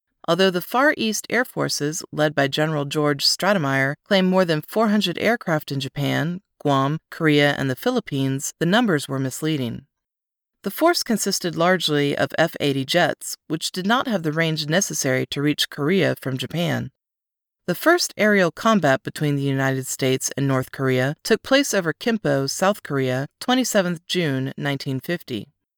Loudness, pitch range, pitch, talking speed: -21 LUFS, 140-195 Hz, 155 Hz, 155 wpm